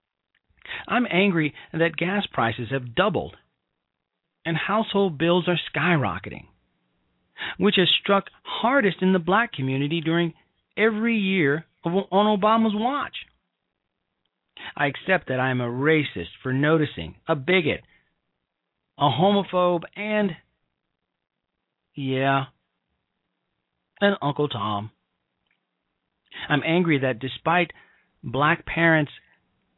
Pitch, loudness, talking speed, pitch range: 165 Hz, -23 LUFS, 105 wpm, 135-190 Hz